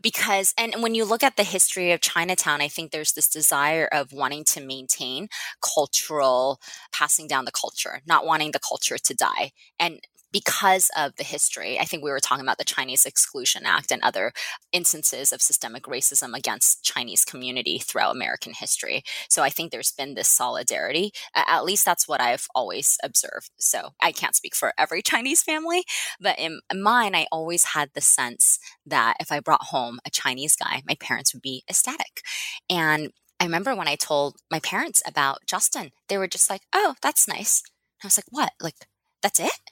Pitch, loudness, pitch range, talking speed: 165 Hz, -22 LUFS, 145-195 Hz, 190 wpm